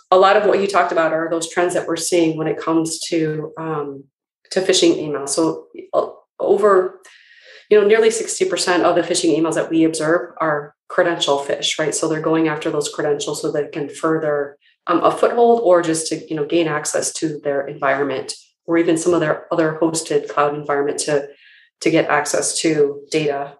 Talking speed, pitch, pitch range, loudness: 200 wpm, 160 Hz, 150-175 Hz, -18 LUFS